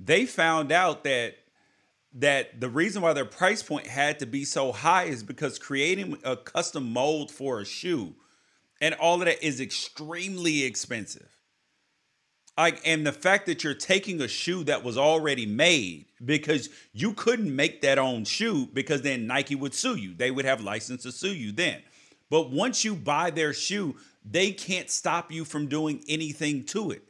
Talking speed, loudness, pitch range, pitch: 180 wpm, -27 LUFS, 140-175 Hz, 150 Hz